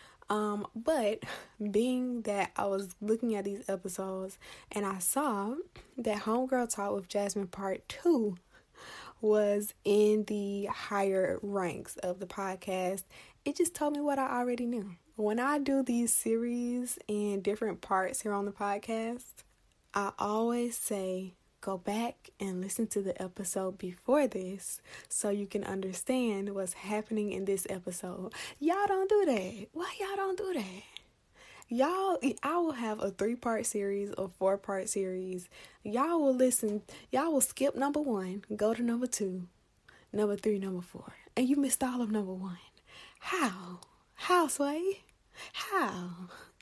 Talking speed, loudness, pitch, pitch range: 150 wpm, -33 LUFS, 210 Hz, 195-250 Hz